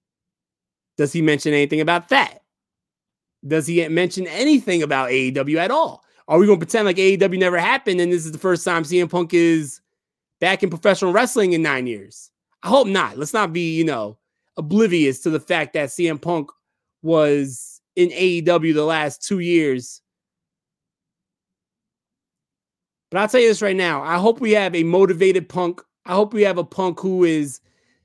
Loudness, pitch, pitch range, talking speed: -18 LUFS, 175 Hz, 155-190 Hz, 180 wpm